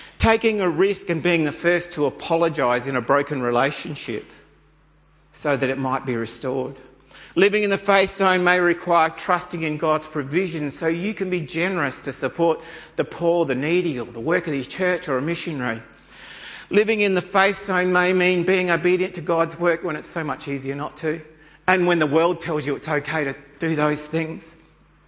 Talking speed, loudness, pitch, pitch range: 195 wpm, -21 LUFS, 165 Hz, 145-180 Hz